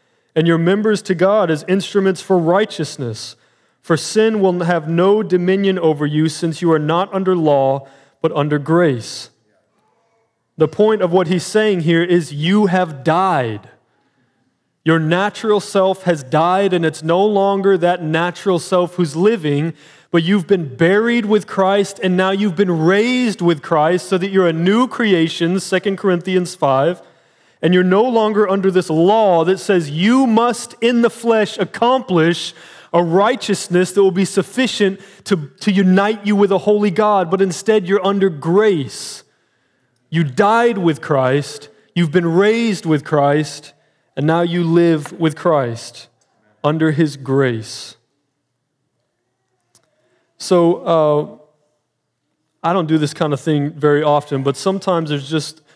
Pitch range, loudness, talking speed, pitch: 150-195 Hz, -16 LUFS, 150 wpm, 175 Hz